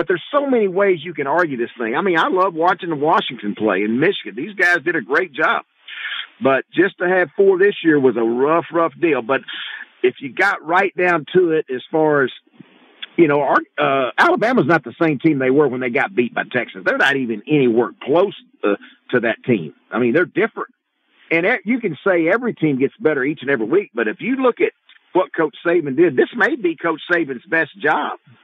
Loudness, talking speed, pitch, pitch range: -18 LUFS, 230 wpm, 170 Hz, 145-205 Hz